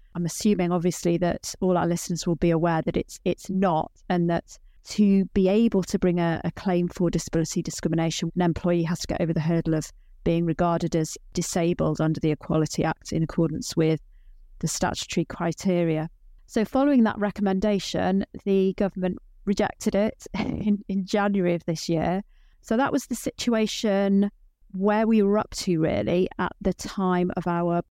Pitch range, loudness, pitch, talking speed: 170-200 Hz, -25 LUFS, 175 Hz, 170 wpm